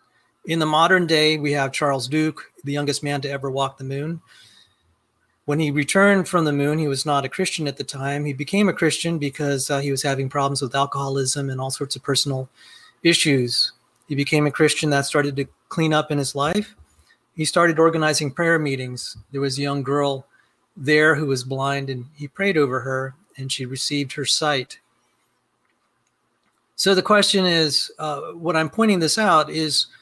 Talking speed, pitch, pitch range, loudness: 190 wpm, 145 Hz, 140-160 Hz, -21 LUFS